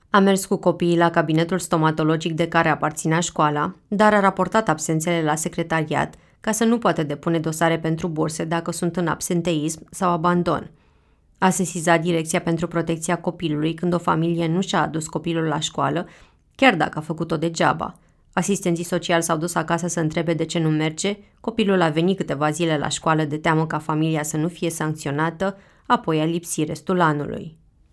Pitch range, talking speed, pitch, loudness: 160-175 Hz, 175 wpm, 170 Hz, -21 LUFS